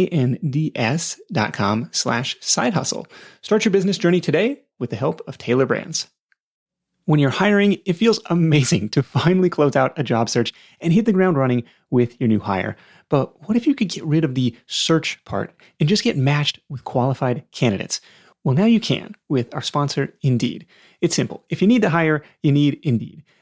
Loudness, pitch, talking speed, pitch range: -20 LUFS, 155 Hz, 185 wpm, 135-185 Hz